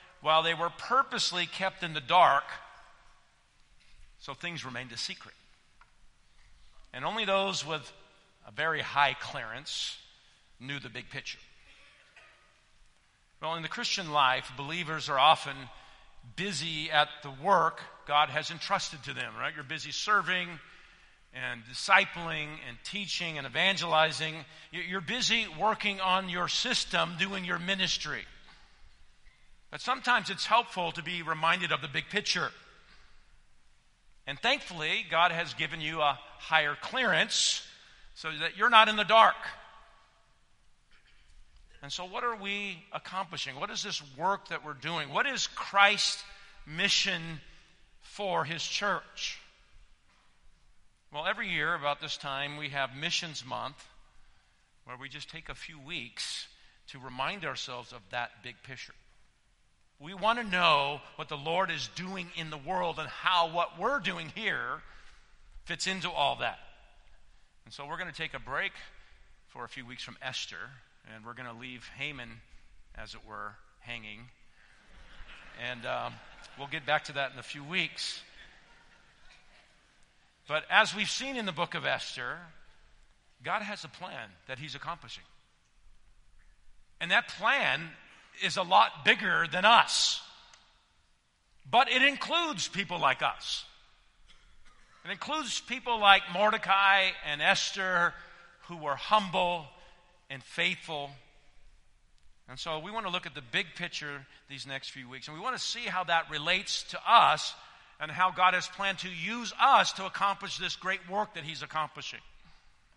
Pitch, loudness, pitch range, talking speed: 165 Hz, -29 LUFS, 145-195 Hz, 145 wpm